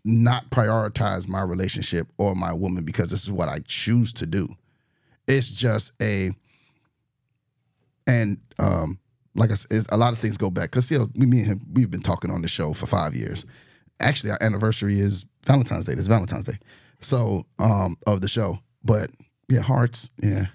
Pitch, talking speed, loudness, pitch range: 110 Hz, 185 wpm, -23 LUFS, 95-125 Hz